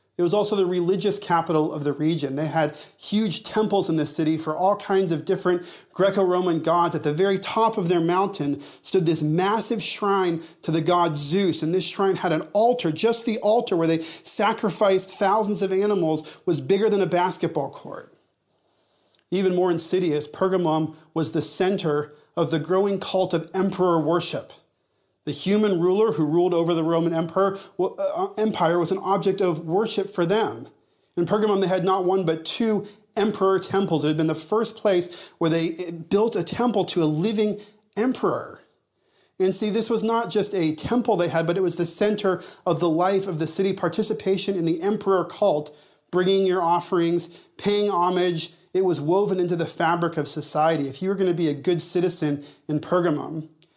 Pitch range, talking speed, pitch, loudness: 165-200 Hz, 185 wpm, 180 Hz, -23 LUFS